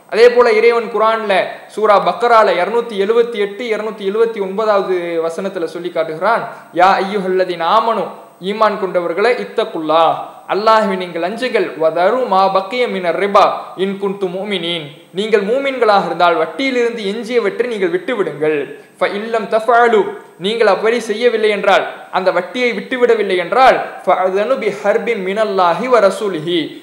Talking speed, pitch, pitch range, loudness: 120 wpm, 210 Hz, 185-235 Hz, -15 LUFS